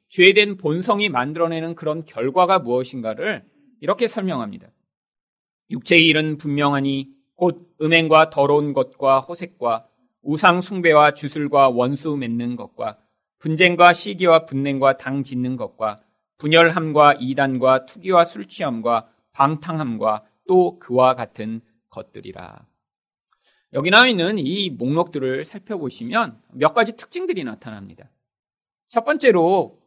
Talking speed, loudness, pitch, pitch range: 275 characters per minute, -18 LUFS, 150 Hz, 130-175 Hz